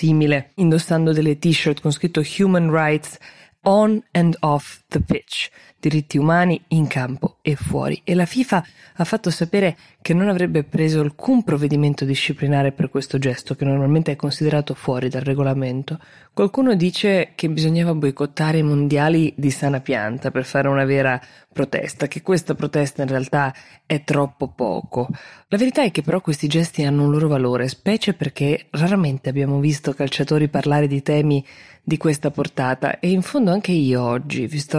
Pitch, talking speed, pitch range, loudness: 150 Hz, 165 wpm, 140-170 Hz, -20 LUFS